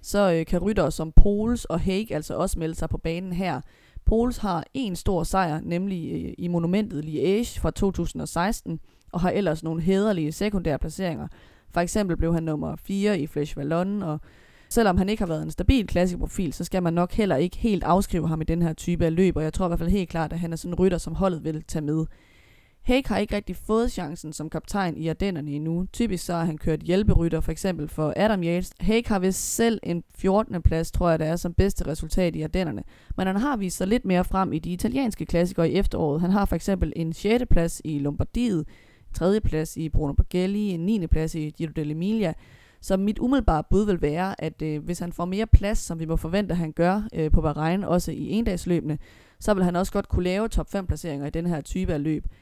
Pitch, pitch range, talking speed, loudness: 175 Hz, 160-195 Hz, 230 wpm, -25 LUFS